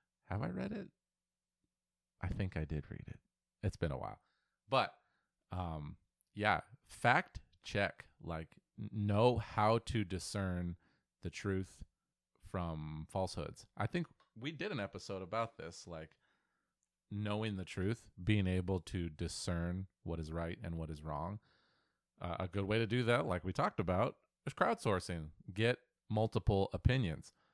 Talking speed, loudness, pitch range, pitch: 145 wpm, -39 LUFS, 85-105 Hz, 95 Hz